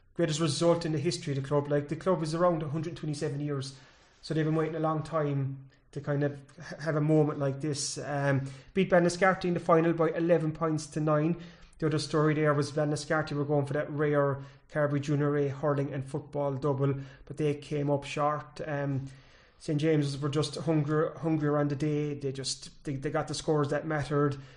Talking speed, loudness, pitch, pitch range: 205 wpm, -30 LUFS, 150 Hz, 145-160 Hz